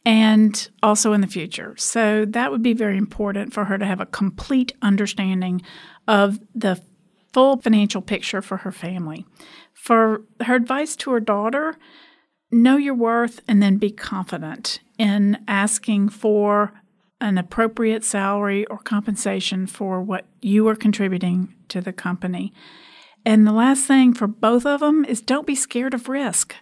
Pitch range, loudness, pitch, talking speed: 195-235 Hz, -20 LUFS, 210 Hz, 155 wpm